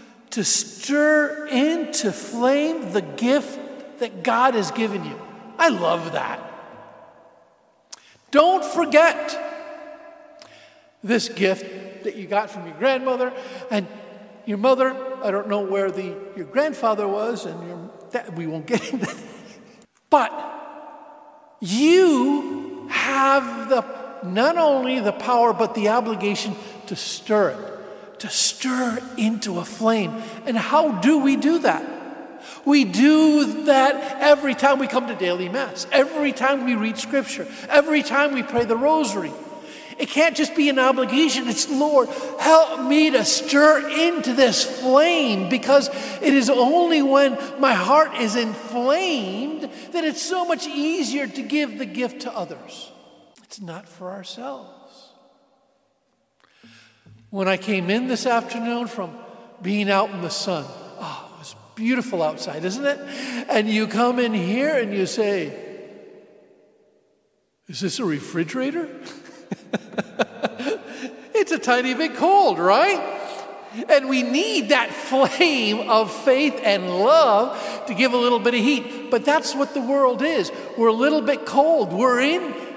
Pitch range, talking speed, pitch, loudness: 220-295 Hz, 140 wpm, 260 Hz, -20 LUFS